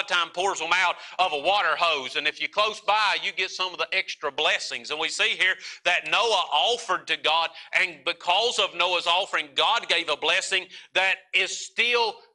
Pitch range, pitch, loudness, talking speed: 170-205 Hz, 185 Hz, -23 LUFS, 210 wpm